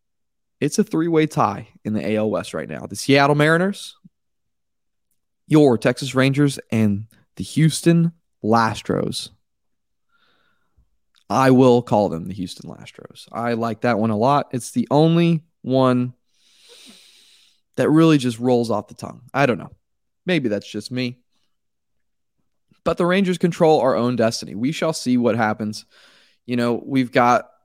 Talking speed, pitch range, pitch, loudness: 150 wpm, 115-160 Hz, 125 Hz, -19 LUFS